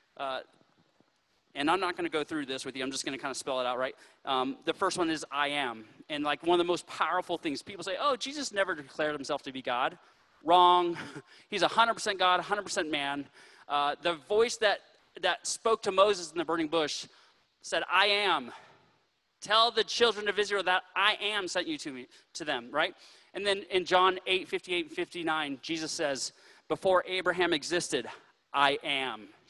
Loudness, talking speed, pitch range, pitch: -30 LUFS, 195 wpm, 150-205 Hz, 180 Hz